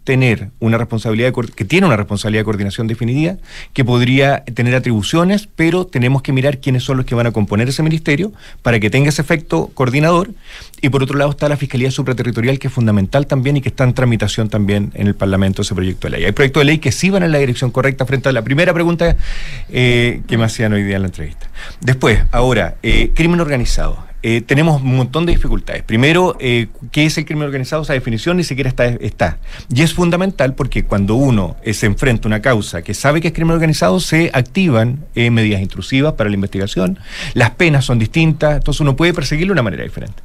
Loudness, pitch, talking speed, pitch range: -15 LUFS, 130 Hz, 220 wpm, 110-150 Hz